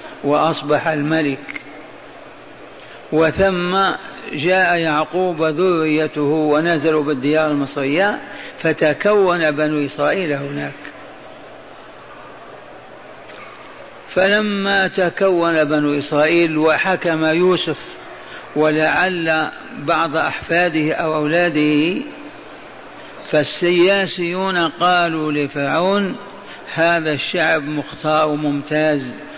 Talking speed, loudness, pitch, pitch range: 65 wpm, -17 LUFS, 160 Hz, 150-180 Hz